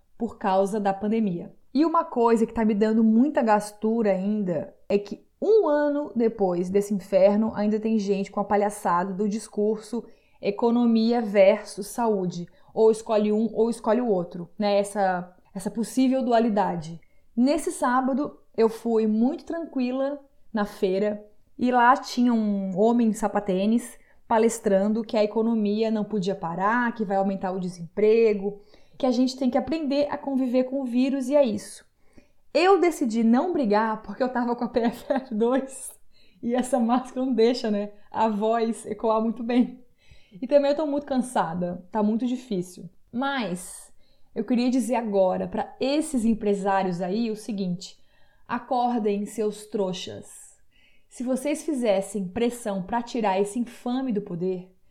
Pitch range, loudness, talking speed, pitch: 205-250 Hz, -24 LUFS, 150 wpm, 220 Hz